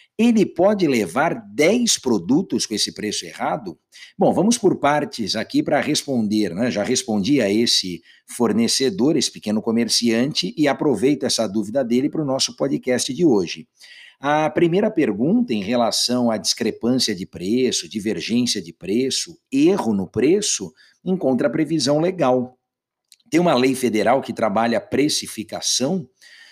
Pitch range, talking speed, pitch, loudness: 115-155 Hz, 145 wpm, 125 Hz, -20 LUFS